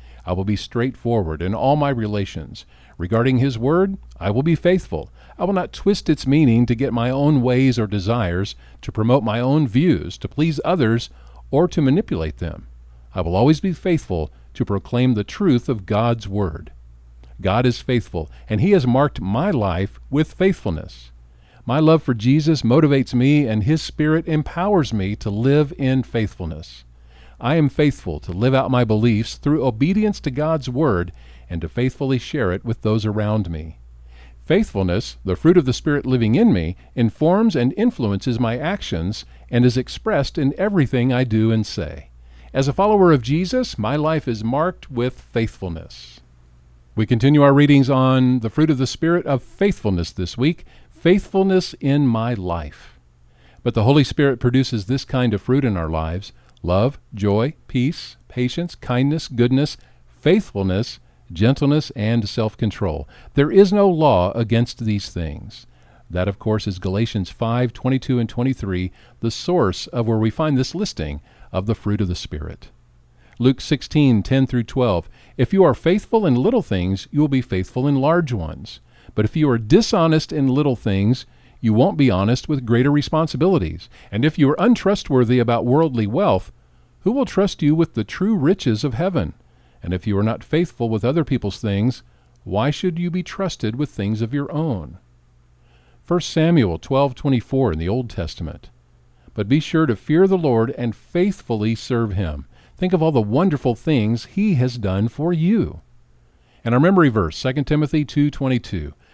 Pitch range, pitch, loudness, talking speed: 100-150 Hz, 120 Hz, -19 LUFS, 175 wpm